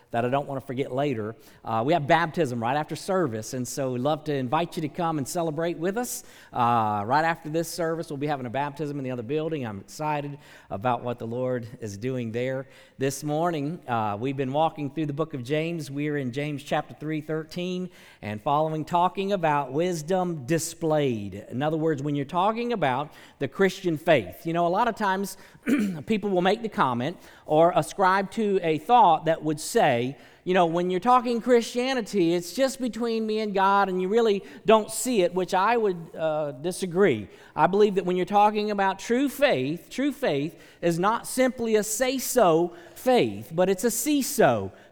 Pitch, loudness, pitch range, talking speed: 165 Hz, -25 LUFS, 145-195 Hz, 200 wpm